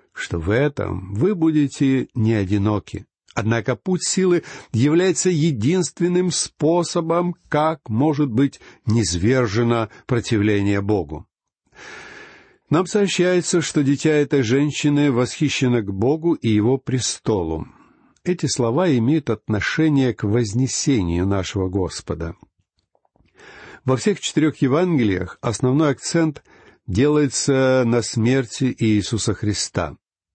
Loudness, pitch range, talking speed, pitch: -20 LUFS, 105-155 Hz, 100 wpm, 130 Hz